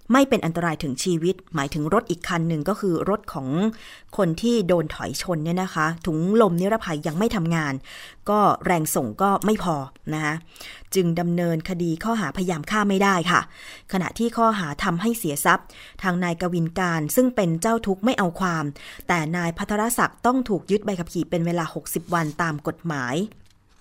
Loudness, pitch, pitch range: -23 LUFS, 175 Hz, 165-205 Hz